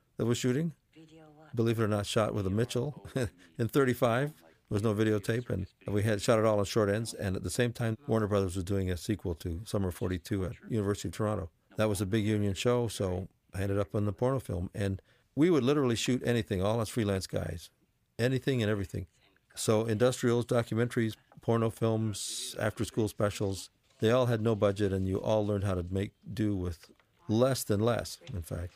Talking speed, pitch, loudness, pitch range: 205 wpm, 110 Hz, -31 LUFS, 100-120 Hz